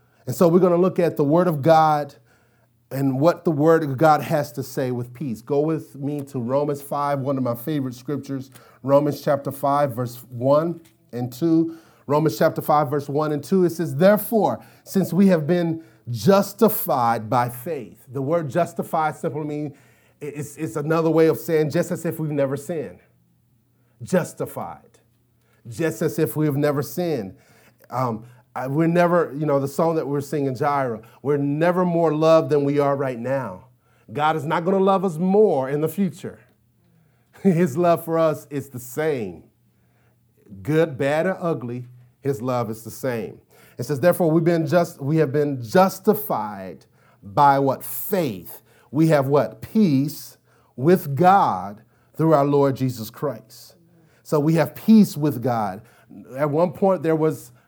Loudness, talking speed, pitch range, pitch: -21 LUFS, 170 wpm, 130-165 Hz, 150 Hz